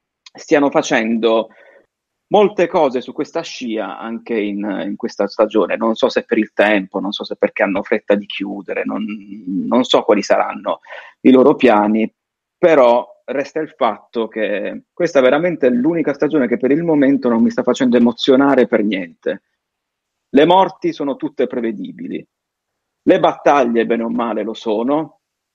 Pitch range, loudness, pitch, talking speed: 115-155 Hz, -16 LUFS, 120 Hz, 160 wpm